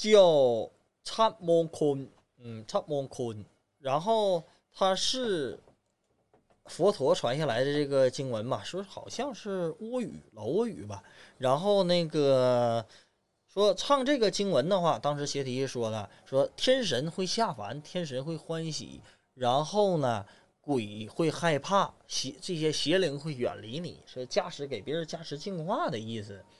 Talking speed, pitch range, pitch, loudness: 205 characters per minute, 130-195 Hz, 155 Hz, -30 LUFS